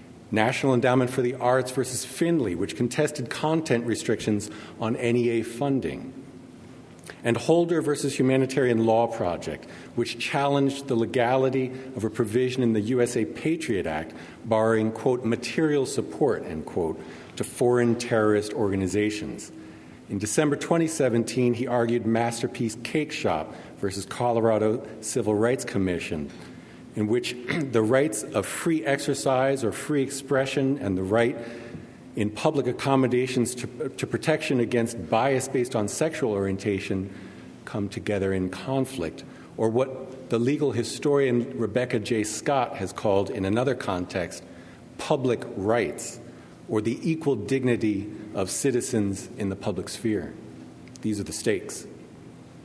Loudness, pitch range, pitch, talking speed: -26 LUFS, 105-130 Hz, 120 Hz, 130 wpm